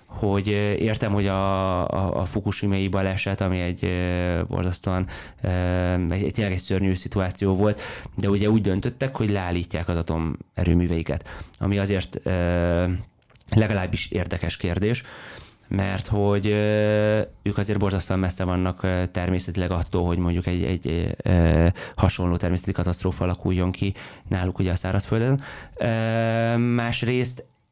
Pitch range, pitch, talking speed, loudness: 90-105 Hz, 95 Hz, 125 wpm, -24 LUFS